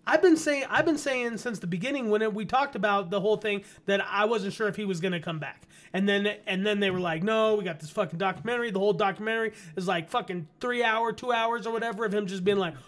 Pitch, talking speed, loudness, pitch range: 210 Hz, 270 wpm, -28 LUFS, 190-230 Hz